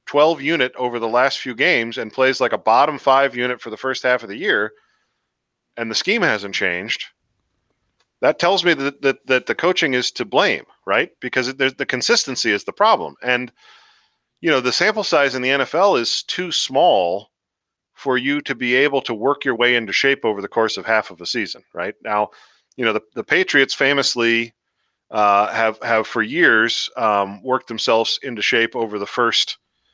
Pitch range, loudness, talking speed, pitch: 115-140 Hz, -18 LUFS, 190 wpm, 130 Hz